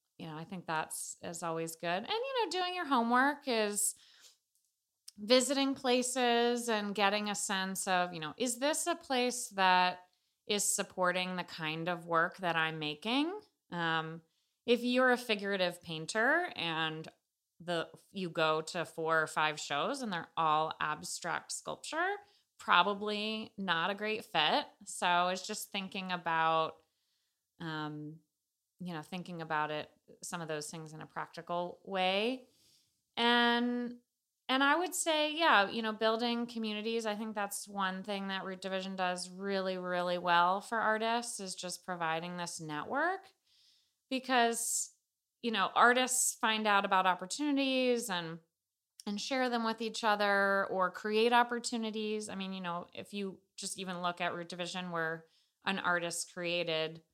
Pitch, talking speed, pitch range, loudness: 195 Hz, 150 wpm, 170-235 Hz, -33 LUFS